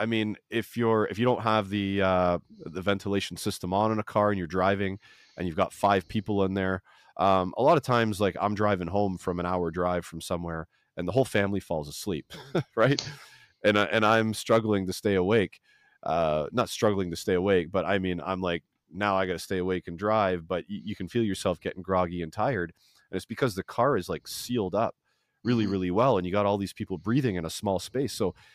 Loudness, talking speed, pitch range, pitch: -28 LUFS, 230 wpm, 90-105 Hz, 100 Hz